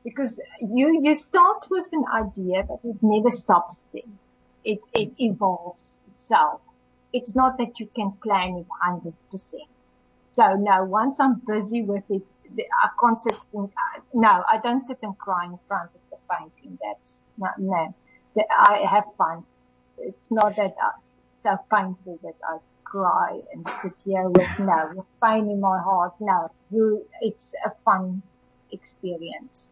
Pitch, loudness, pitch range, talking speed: 210 Hz, -23 LUFS, 185-235 Hz, 160 wpm